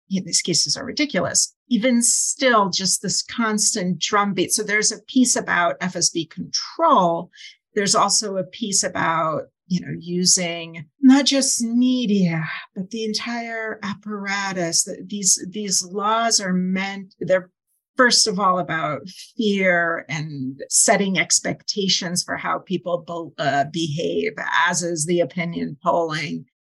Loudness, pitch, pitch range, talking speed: -20 LUFS, 190 Hz, 170-220 Hz, 130 wpm